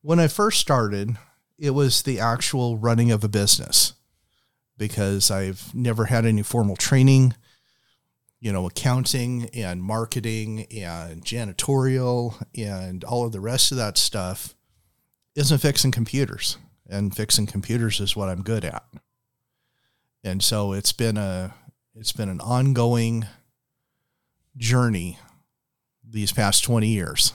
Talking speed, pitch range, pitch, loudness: 130 wpm, 105-125 Hz, 115 Hz, -22 LUFS